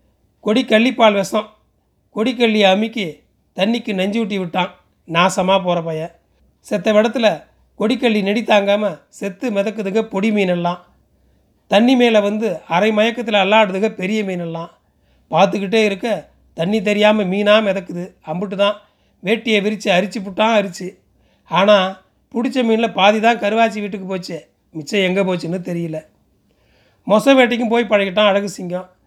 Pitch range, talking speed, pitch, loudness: 185-220 Hz, 125 wpm, 205 Hz, -17 LUFS